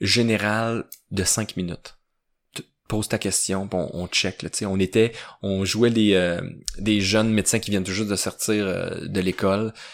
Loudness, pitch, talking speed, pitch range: -23 LUFS, 100 Hz, 180 wpm, 95-110 Hz